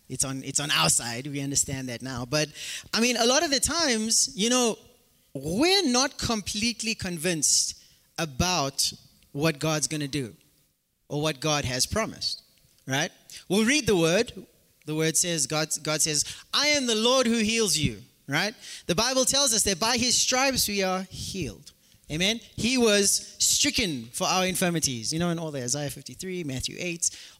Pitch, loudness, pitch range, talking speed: 170 Hz, -24 LUFS, 145-225 Hz, 175 wpm